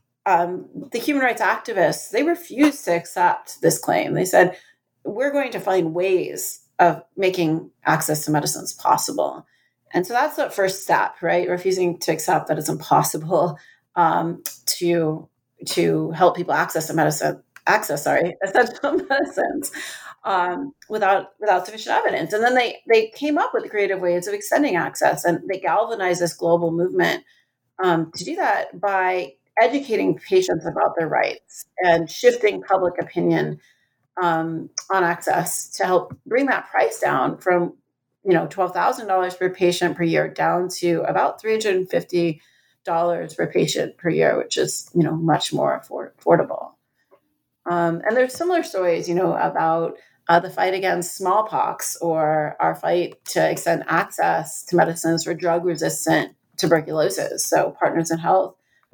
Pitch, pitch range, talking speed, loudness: 180 Hz, 170-230 Hz, 150 wpm, -21 LUFS